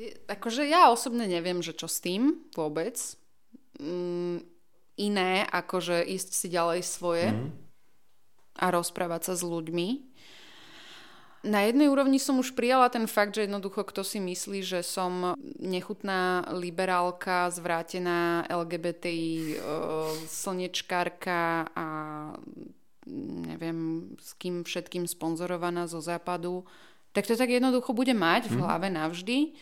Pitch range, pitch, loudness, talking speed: 170-210 Hz, 180 Hz, -29 LUFS, 115 wpm